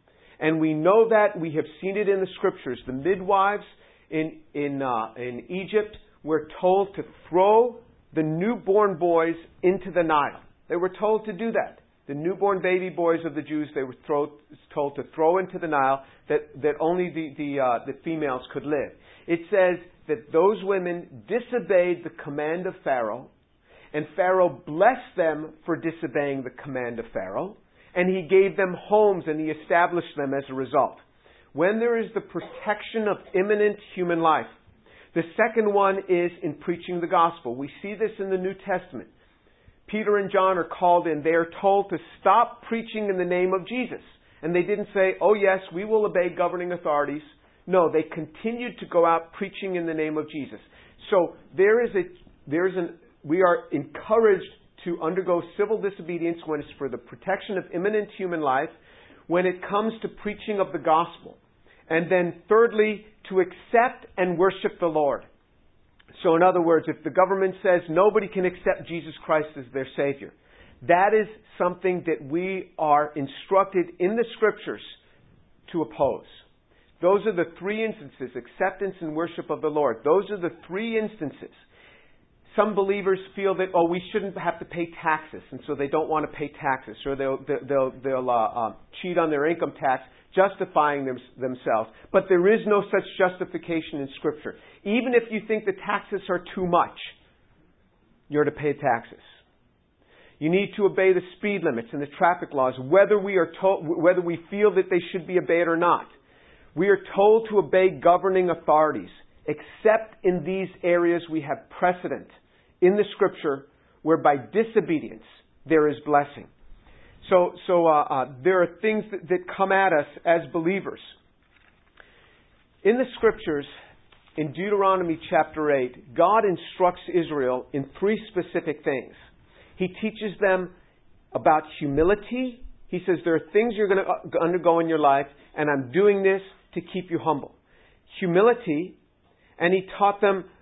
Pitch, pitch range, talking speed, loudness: 175 Hz, 155-195 Hz, 170 wpm, -24 LUFS